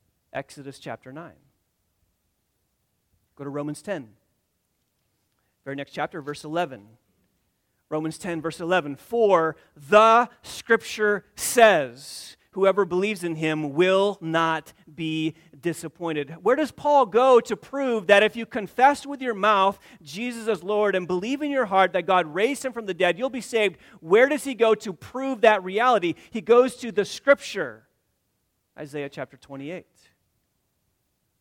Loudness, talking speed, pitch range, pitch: -23 LUFS, 145 wpm, 145-230 Hz, 185 Hz